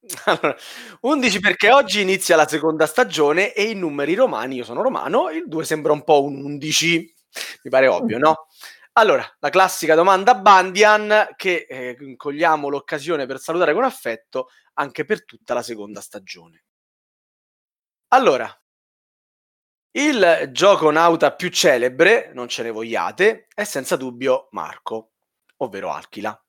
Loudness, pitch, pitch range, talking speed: -18 LUFS, 165 Hz, 145-205 Hz, 140 wpm